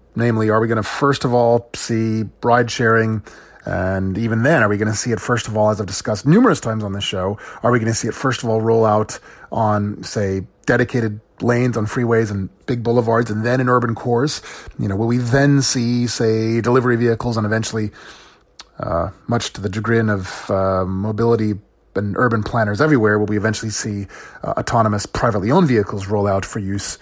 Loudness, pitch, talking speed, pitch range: -18 LUFS, 110 Hz, 205 wpm, 105-120 Hz